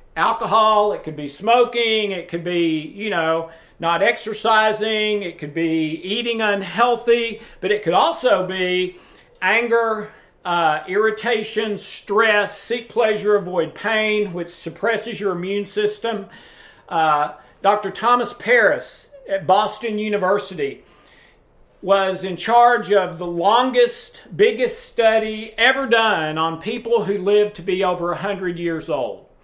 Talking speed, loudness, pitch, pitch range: 125 wpm, -19 LUFS, 210 Hz, 180-225 Hz